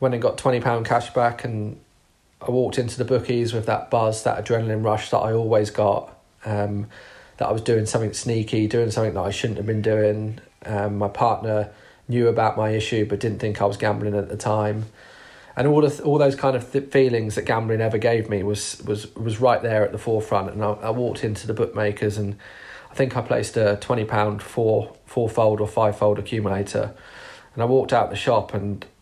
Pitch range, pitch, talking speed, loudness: 105-120 Hz, 110 Hz, 215 wpm, -22 LUFS